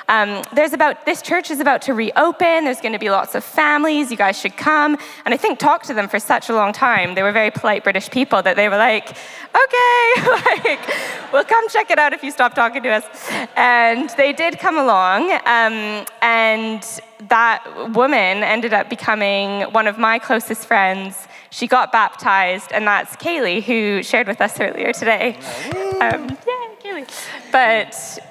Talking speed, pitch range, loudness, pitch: 185 wpm, 215-305 Hz, -16 LUFS, 235 Hz